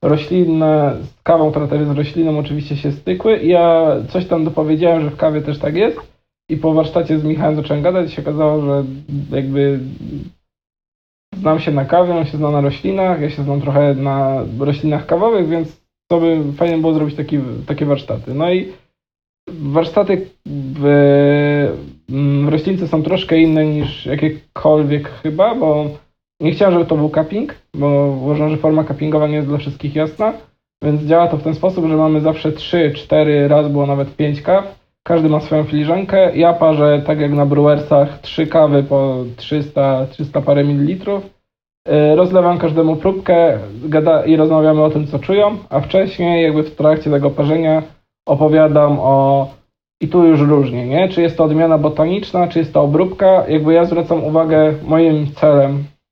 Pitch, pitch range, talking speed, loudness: 155 Hz, 145-165 Hz, 165 wpm, -14 LUFS